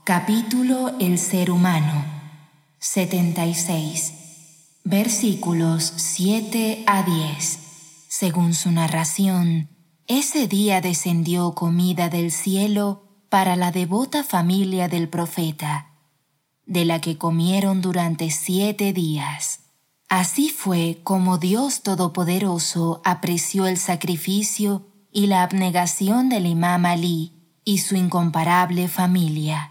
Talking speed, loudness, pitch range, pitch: 100 wpm, -21 LUFS, 165-195 Hz, 180 Hz